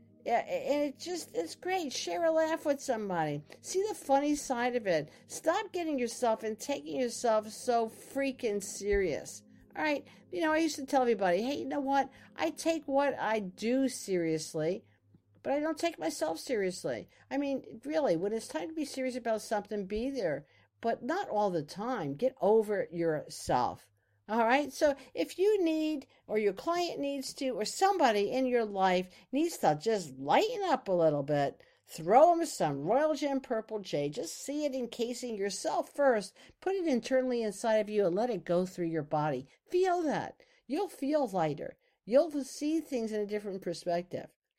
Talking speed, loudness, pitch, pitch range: 180 wpm, -32 LUFS, 250 Hz, 200-290 Hz